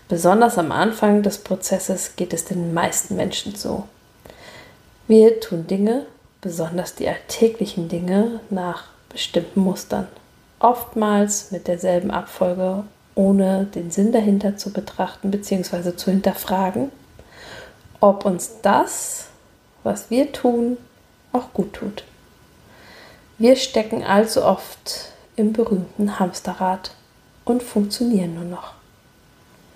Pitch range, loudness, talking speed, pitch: 180-225 Hz, -20 LUFS, 110 wpm, 195 Hz